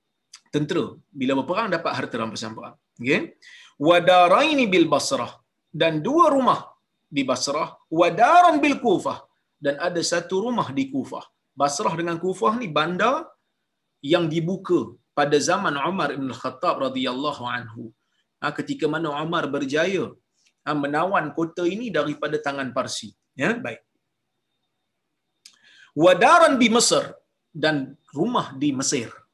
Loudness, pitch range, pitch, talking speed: -22 LUFS, 145-190 Hz, 165 Hz, 125 wpm